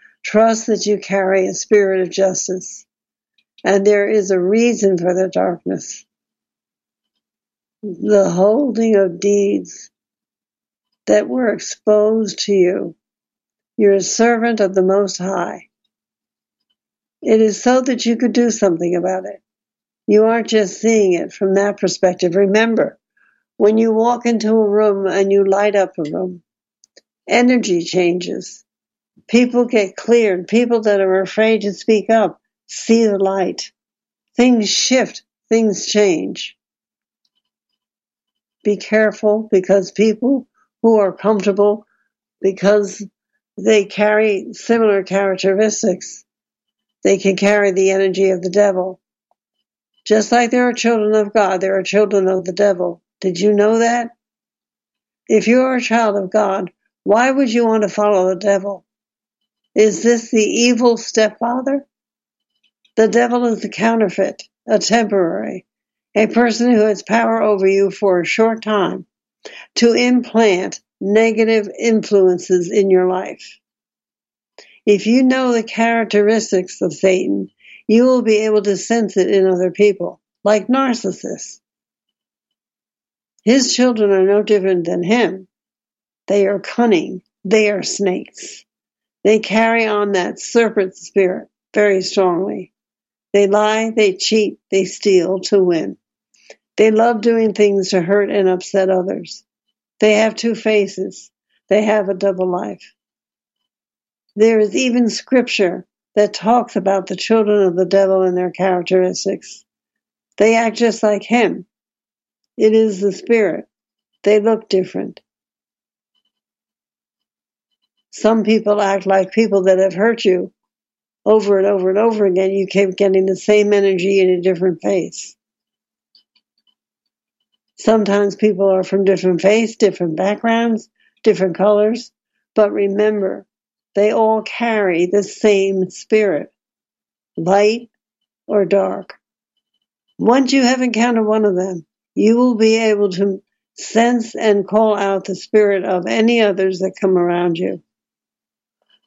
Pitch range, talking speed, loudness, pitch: 195-225 Hz, 130 wpm, -15 LUFS, 205 Hz